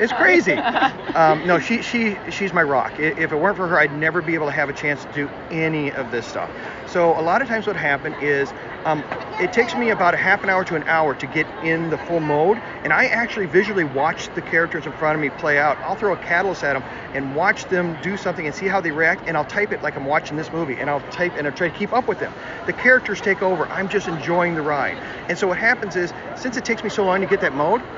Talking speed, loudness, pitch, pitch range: 270 wpm, -20 LUFS, 170 Hz, 155-195 Hz